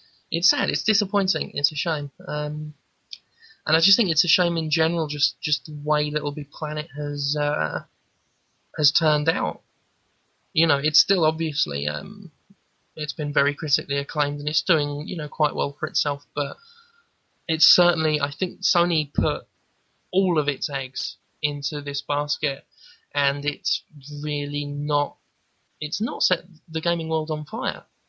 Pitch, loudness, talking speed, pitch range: 150 Hz, -23 LUFS, 160 wpm, 145-165 Hz